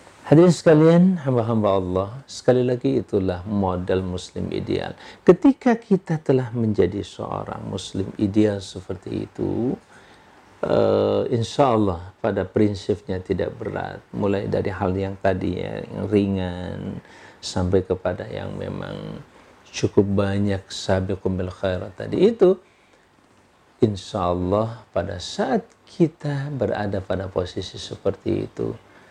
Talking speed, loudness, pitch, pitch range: 110 wpm, -22 LUFS, 100 Hz, 95-125 Hz